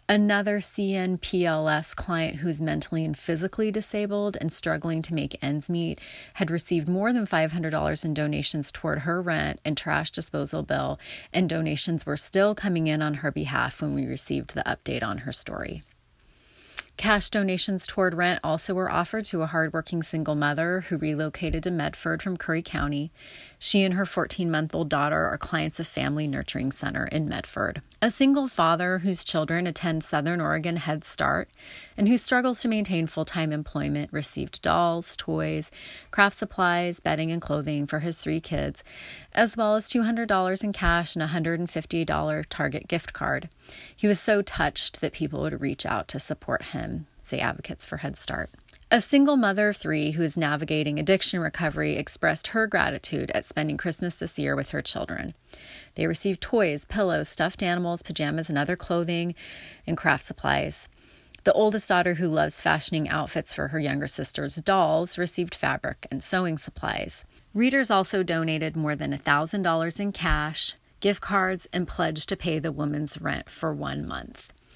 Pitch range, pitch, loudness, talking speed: 155-190 Hz, 170 Hz, -26 LUFS, 170 wpm